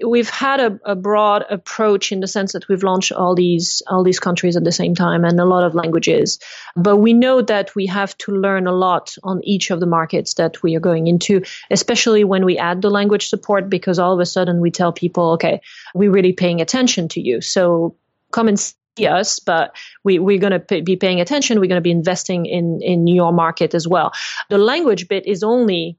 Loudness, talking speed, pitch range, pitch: -16 LUFS, 225 wpm, 175-205 Hz, 185 Hz